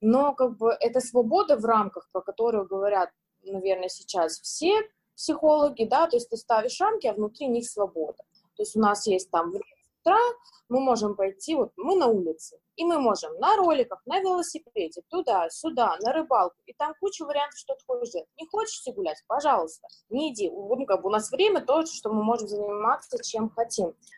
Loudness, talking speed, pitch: -26 LUFS, 180 wpm, 250 Hz